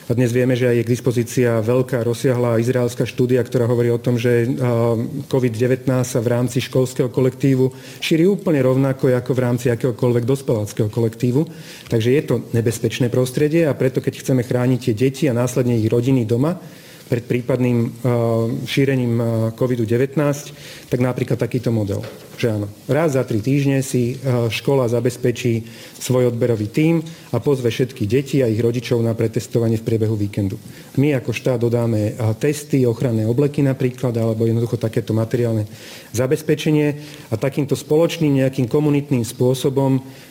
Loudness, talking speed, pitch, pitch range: -19 LUFS, 150 wpm, 125 Hz, 120-135 Hz